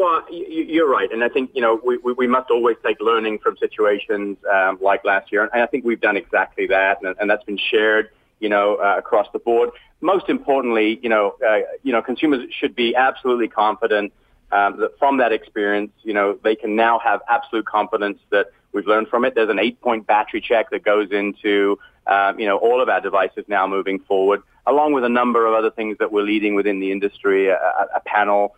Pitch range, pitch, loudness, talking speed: 100-120 Hz, 110 Hz, -19 LUFS, 215 wpm